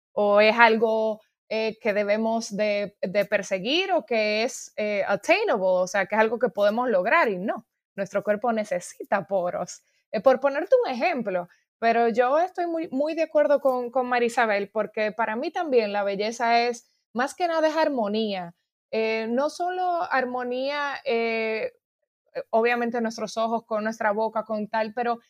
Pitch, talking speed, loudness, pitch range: 230 Hz, 165 wpm, -24 LUFS, 210-265 Hz